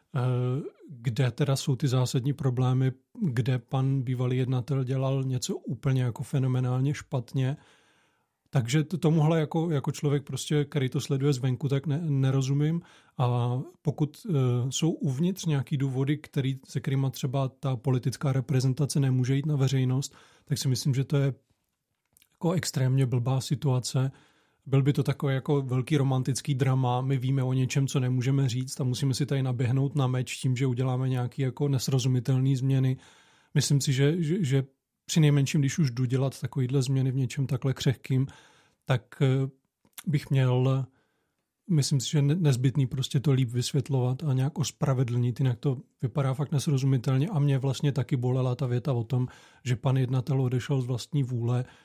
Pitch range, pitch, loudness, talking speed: 130-145 Hz, 135 Hz, -28 LUFS, 160 wpm